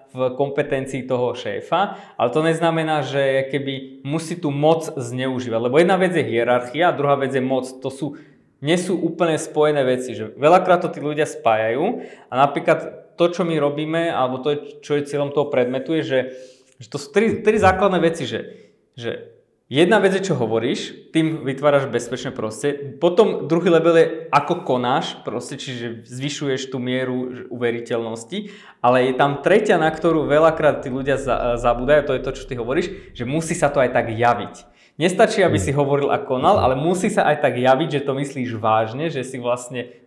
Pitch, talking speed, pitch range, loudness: 140 Hz, 185 wpm, 125-160 Hz, -20 LUFS